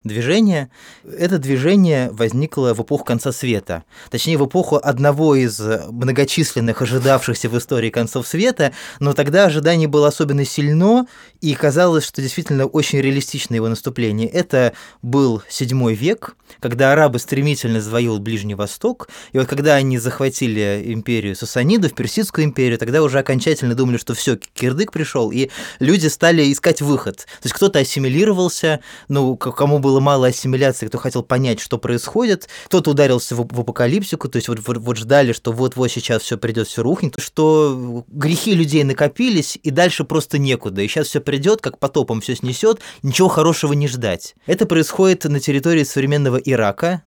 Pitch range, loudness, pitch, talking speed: 120-155 Hz, -17 LUFS, 135 Hz, 160 wpm